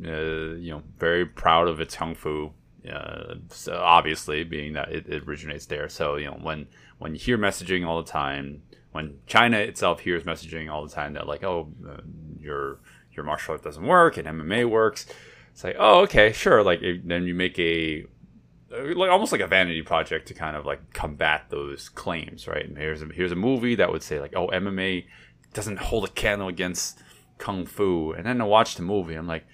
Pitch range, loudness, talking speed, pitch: 75-90 Hz, -24 LUFS, 205 wpm, 80 Hz